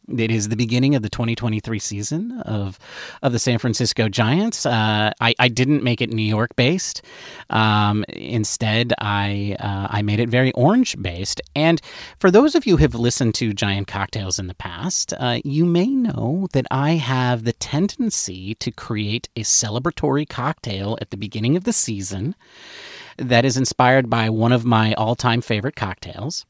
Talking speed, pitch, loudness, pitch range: 175 wpm, 120 Hz, -20 LUFS, 105-140 Hz